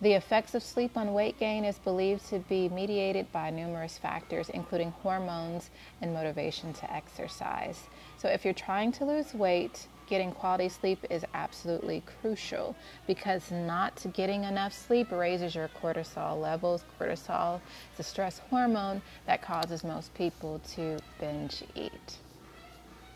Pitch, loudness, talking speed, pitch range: 185 Hz, -33 LUFS, 145 wpm, 170-200 Hz